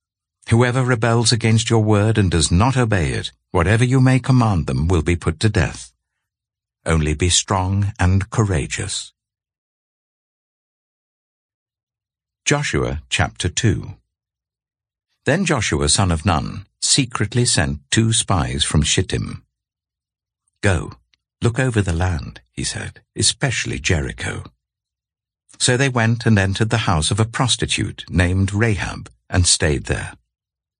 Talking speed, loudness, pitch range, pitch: 125 wpm, -18 LUFS, 85-115 Hz, 105 Hz